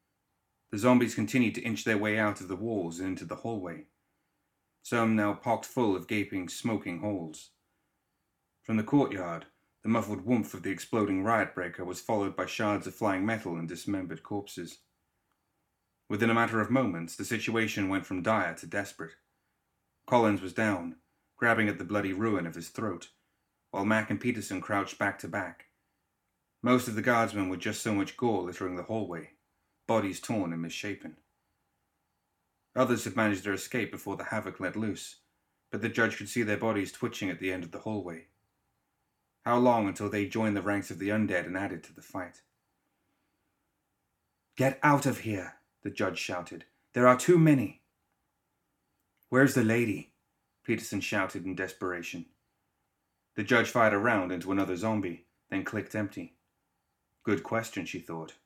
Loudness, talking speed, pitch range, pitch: -30 LUFS, 165 wpm, 95-115 Hz, 105 Hz